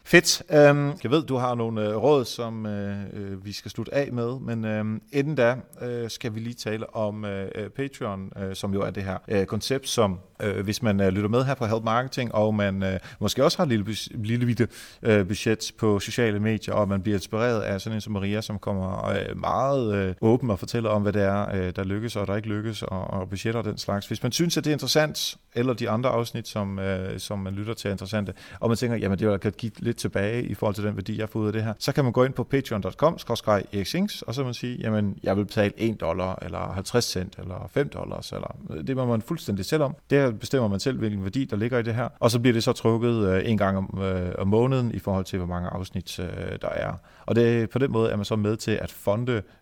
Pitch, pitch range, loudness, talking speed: 110 Hz, 100-120 Hz, -26 LUFS, 245 wpm